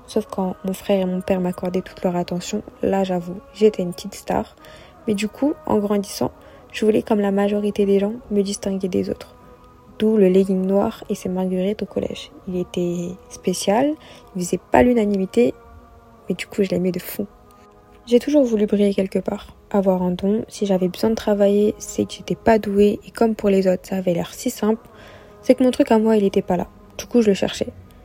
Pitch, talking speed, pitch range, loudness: 200 Hz, 215 wpm, 185-215 Hz, -20 LUFS